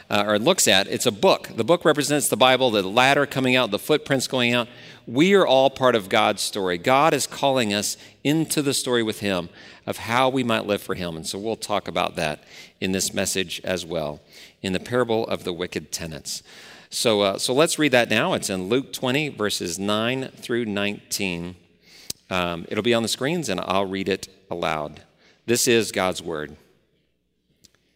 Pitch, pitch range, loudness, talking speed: 105 Hz, 95-130 Hz, -22 LUFS, 195 wpm